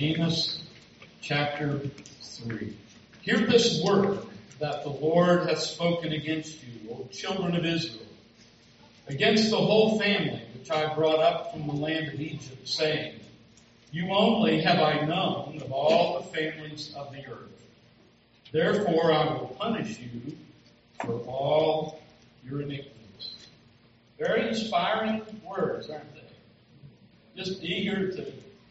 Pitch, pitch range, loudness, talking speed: 155 Hz, 120-170 Hz, -27 LUFS, 125 wpm